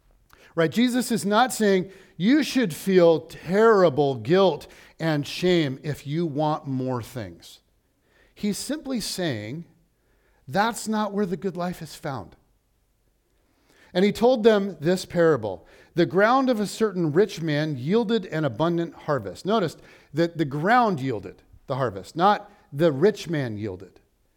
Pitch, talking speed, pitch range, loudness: 175 Hz, 140 wpm, 155-205 Hz, -23 LUFS